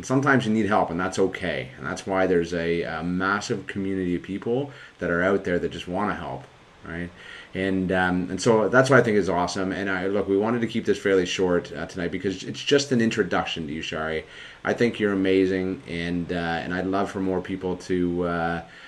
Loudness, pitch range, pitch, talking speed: -24 LUFS, 85-100 Hz, 95 Hz, 225 wpm